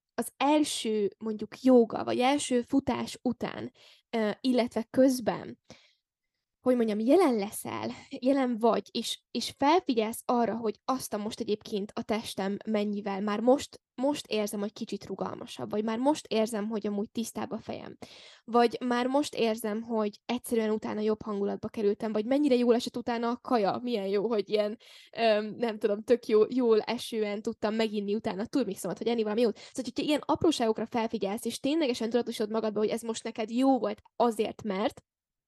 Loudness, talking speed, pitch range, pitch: -29 LUFS, 165 wpm, 215-245 Hz, 225 Hz